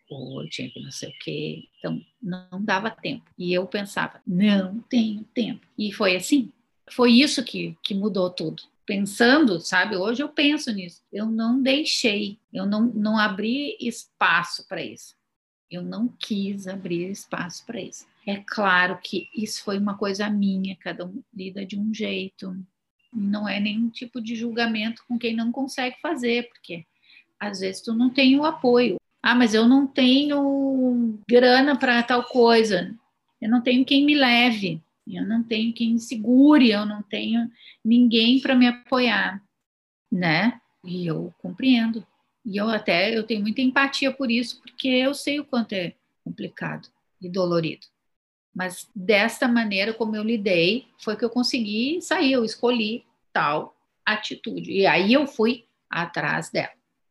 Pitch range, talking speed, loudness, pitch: 200-250 Hz, 160 wpm, -22 LUFS, 230 Hz